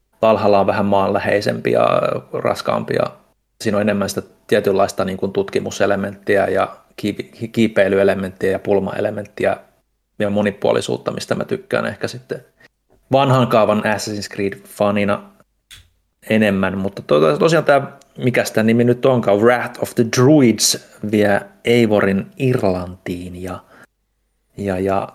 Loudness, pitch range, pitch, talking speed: -17 LUFS, 95-110 Hz, 100 Hz, 120 wpm